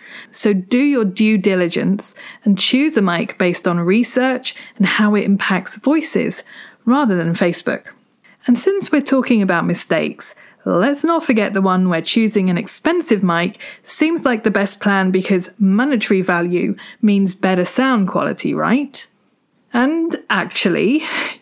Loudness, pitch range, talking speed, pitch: -16 LUFS, 190-255 Hz, 145 wpm, 215 Hz